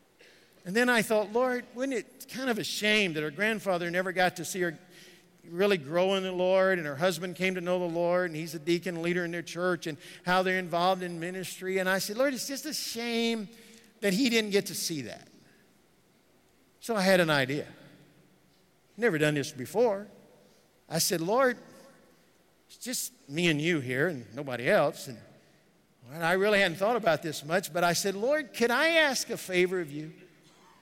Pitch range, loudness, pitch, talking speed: 170-220 Hz, -28 LUFS, 185 Hz, 195 wpm